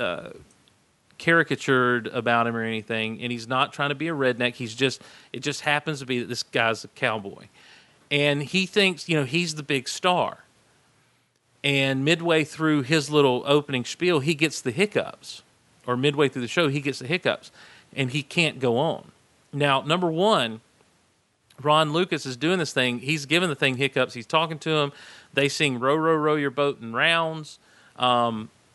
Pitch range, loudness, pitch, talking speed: 125-160 Hz, -24 LUFS, 145 Hz, 185 wpm